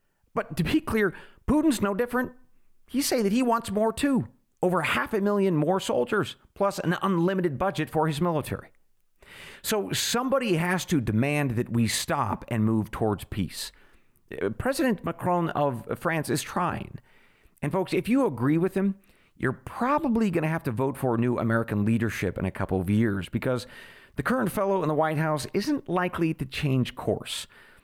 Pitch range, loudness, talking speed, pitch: 120-205 Hz, -27 LUFS, 175 wpm, 165 Hz